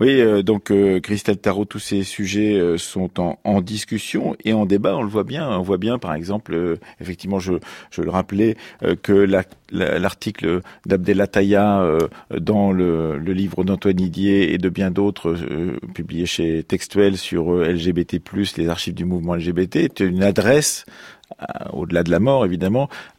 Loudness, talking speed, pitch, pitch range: -20 LUFS, 180 wpm, 95 Hz, 90-100 Hz